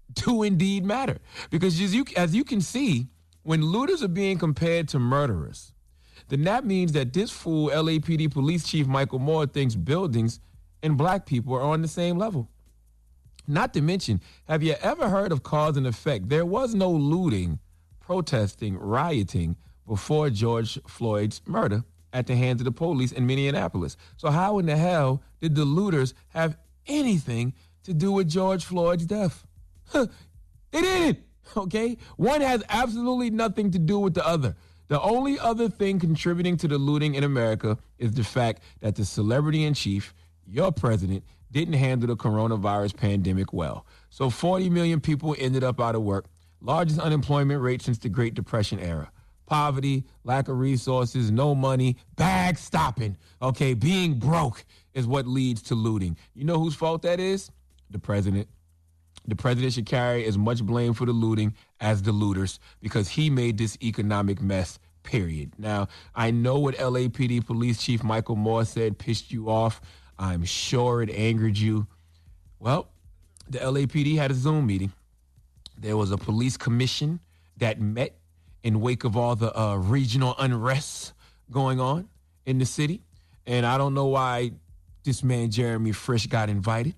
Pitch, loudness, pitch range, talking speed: 125 Hz, -26 LUFS, 105-155 Hz, 165 wpm